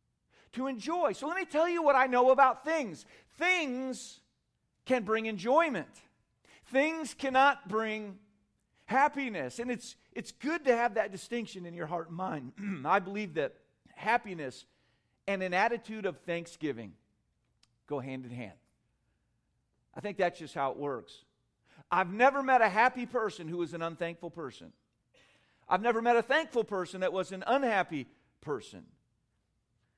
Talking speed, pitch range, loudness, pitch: 150 wpm, 160-255 Hz, -31 LUFS, 205 Hz